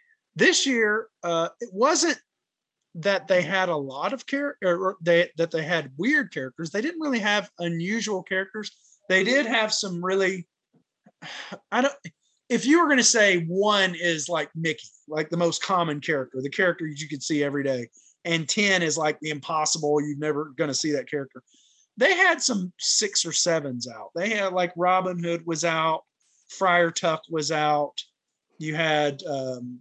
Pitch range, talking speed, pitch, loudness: 155-205 Hz, 175 wpm, 170 Hz, -24 LUFS